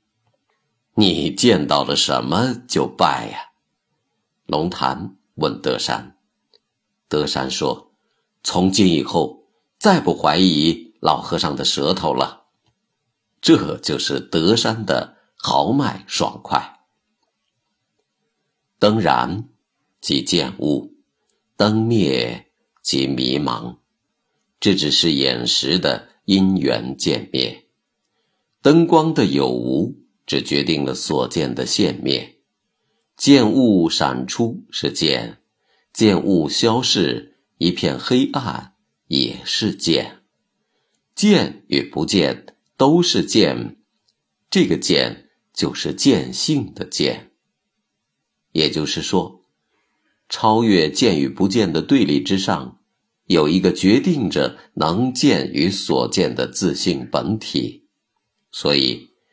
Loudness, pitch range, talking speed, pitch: -18 LUFS, 70-115 Hz, 145 characters per minute, 95 Hz